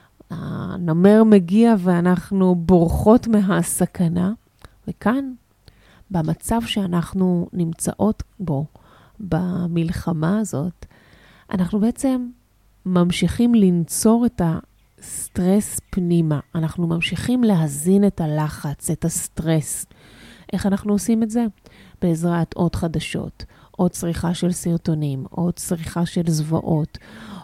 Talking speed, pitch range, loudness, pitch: 90 wpm, 165-205 Hz, -20 LUFS, 180 Hz